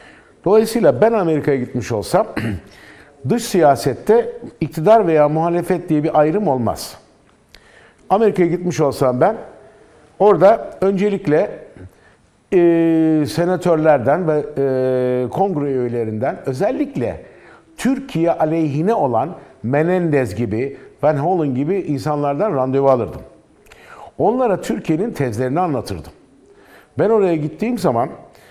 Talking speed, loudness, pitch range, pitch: 95 wpm, -17 LUFS, 135-185 Hz, 155 Hz